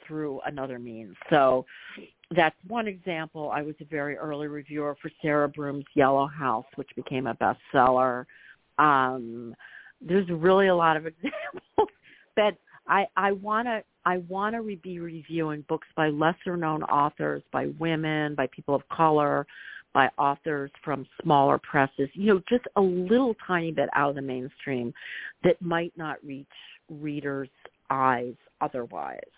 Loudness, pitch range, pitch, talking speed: -27 LUFS, 135-175 Hz, 150 Hz, 145 wpm